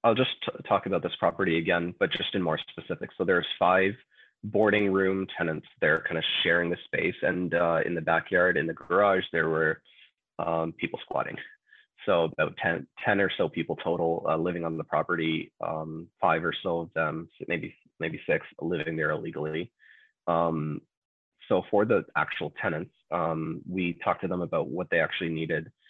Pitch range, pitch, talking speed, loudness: 80-95 Hz, 85 Hz, 185 wpm, -28 LUFS